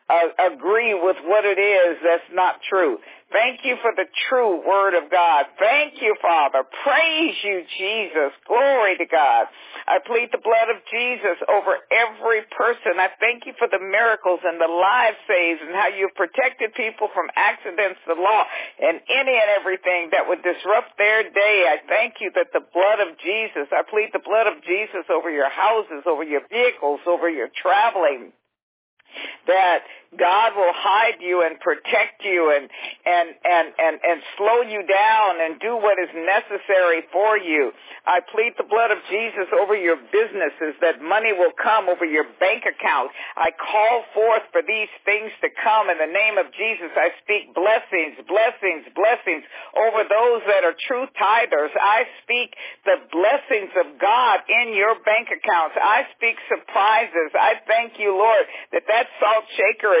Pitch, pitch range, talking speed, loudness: 210 Hz, 180-230 Hz, 170 wpm, -19 LUFS